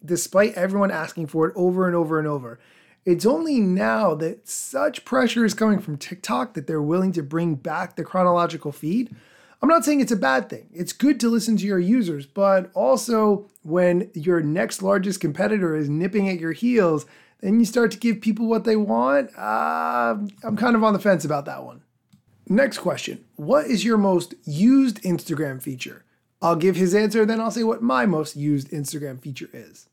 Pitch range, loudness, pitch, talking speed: 160-225 Hz, -22 LUFS, 190 Hz, 195 wpm